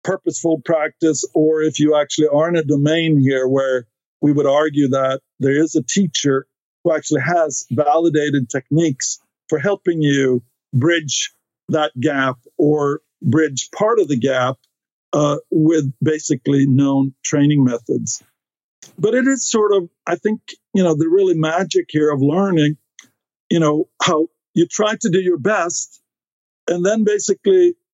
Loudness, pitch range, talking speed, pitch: -17 LUFS, 140-175 Hz, 150 wpm, 155 Hz